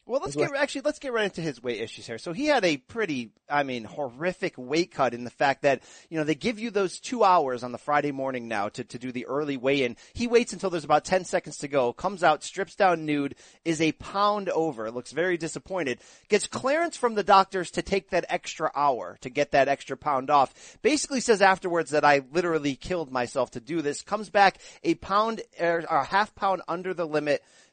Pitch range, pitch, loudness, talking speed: 140-195 Hz, 165 Hz, -26 LUFS, 225 wpm